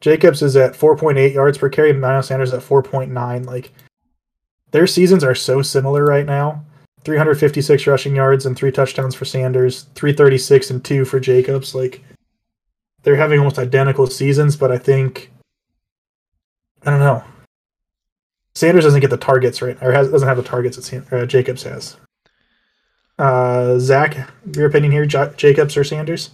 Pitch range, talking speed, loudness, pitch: 130-145 Hz, 175 wpm, -15 LUFS, 135 Hz